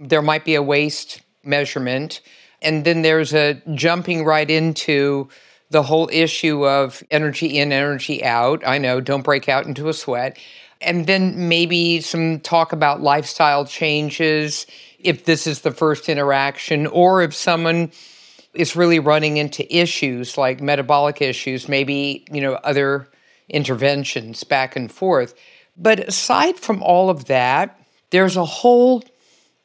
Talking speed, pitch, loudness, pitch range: 145 wpm, 150 Hz, -18 LUFS, 140-170 Hz